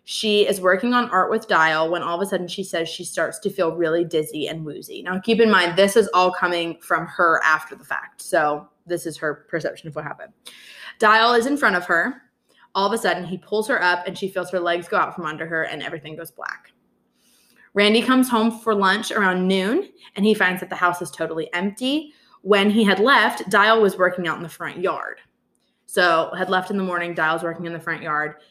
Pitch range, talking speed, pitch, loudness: 170-210 Hz, 235 wpm, 185 Hz, -20 LUFS